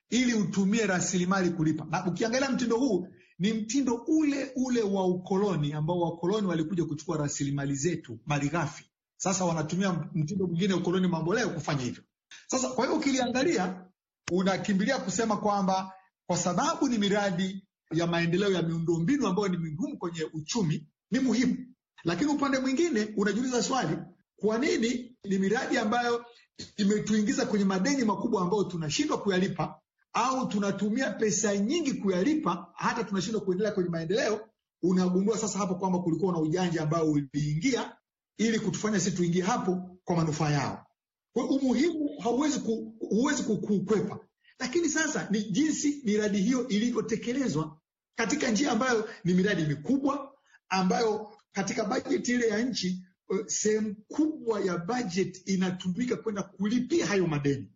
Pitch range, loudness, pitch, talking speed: 180-235 Hz, -29 LUFS, 200 Hz, 125 wpm